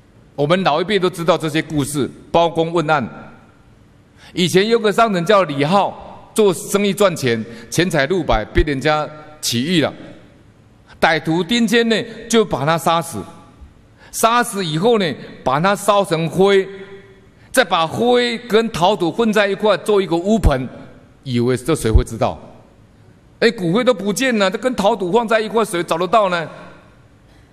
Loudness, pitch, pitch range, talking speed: -17 LUFS, 185 Hz, 155-215 Hz, 220 characters per minute